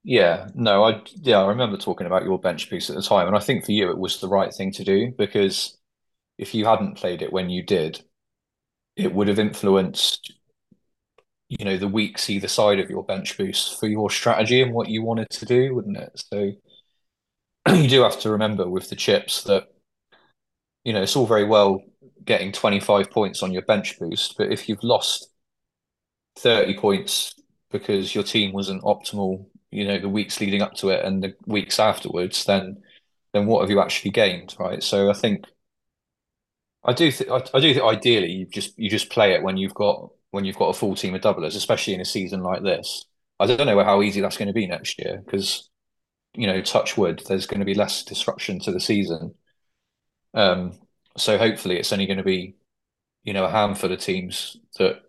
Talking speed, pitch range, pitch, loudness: 205 wpm, 95-110 Hz, 100 Hz, -22 LUFS